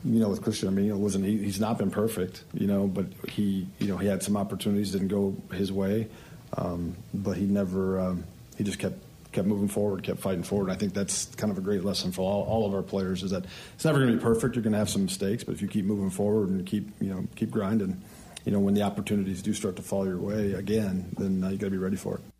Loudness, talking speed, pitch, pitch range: -29 LUFS, 275 wpm, 100 Hz, 95-105 Hz